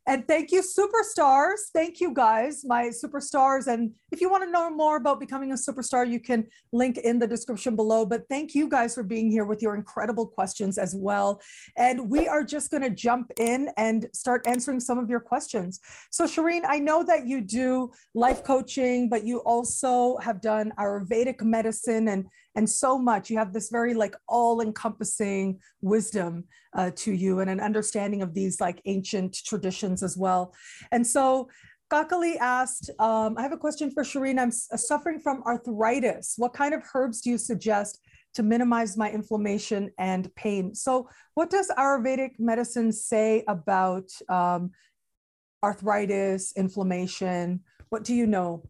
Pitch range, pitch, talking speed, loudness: 210-265 Hz, 235 Hz, 170 wpm, -26 LUFS